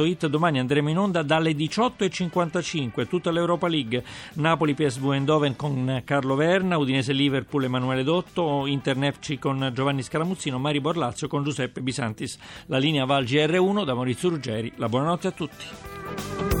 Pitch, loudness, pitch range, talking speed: 145 Hz, -25 LUFS, 135-165 Hz, 150 wpm